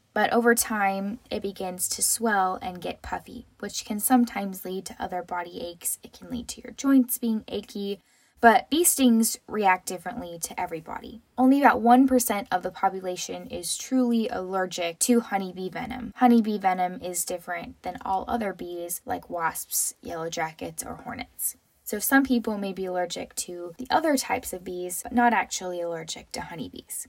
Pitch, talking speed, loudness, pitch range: 205 Hz, 170 wpm, -26 LUFS, 180-240 Hz